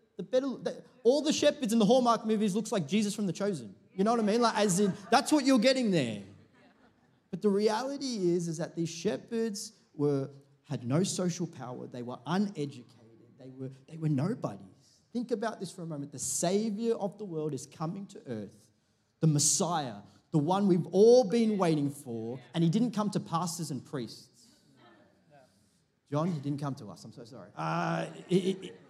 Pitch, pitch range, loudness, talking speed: 180 Hz, 140-215 Hz, -30 LUFS, 195 wpm